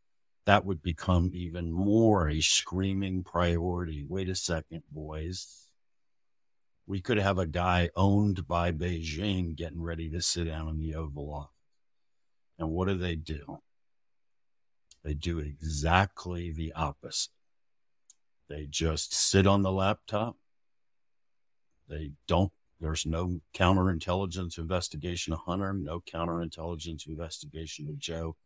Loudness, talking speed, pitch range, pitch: -30 LUFS, 120 wpm, 80-95 Hz, 85 Hz